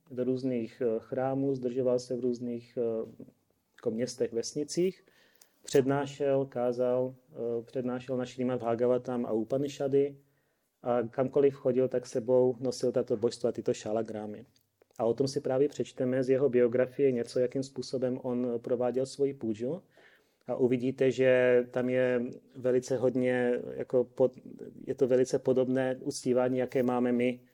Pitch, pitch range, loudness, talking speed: 125 Hz, 125-130 Hz, -30 LUFS, 130 wpm